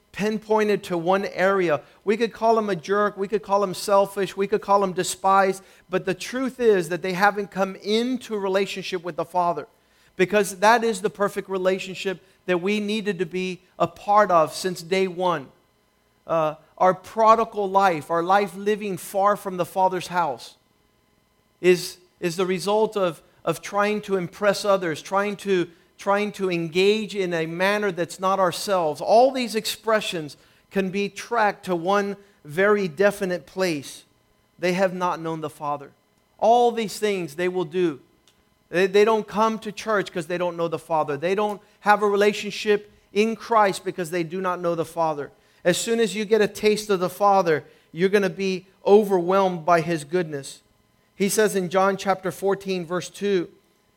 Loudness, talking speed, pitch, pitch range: -23 LUFS, 175 wpm, 195 Hz, 180-205 Hz